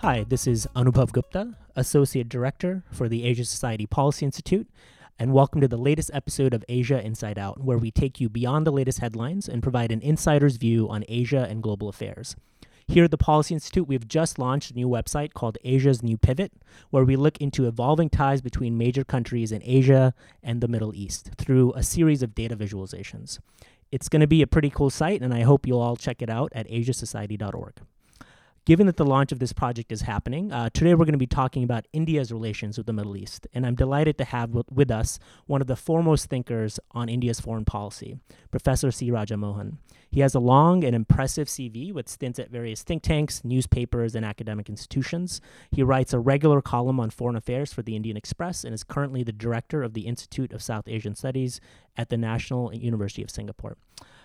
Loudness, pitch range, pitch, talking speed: -25 LUFS, 115-140 Hz, 125 Hz, 205 wpm